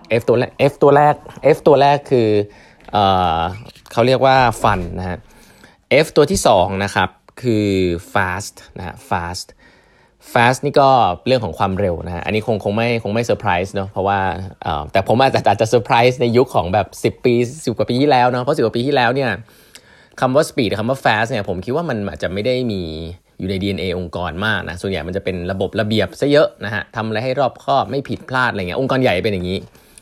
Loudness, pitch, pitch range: -17 LUFS, 105 Hz, 95-125 Hz